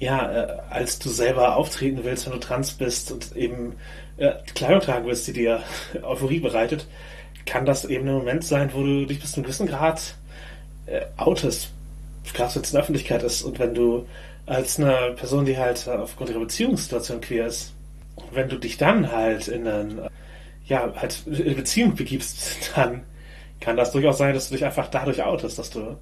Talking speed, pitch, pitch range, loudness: 185 wpm, 130 Hz, 120-150 Hz, -24 LUFS